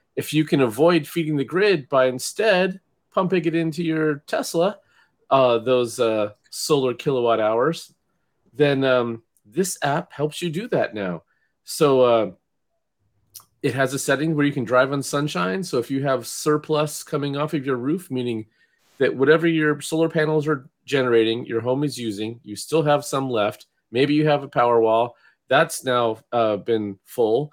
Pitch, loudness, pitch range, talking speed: 135 Hz, -21 LUFS, 115-155 Hz, 170 wpm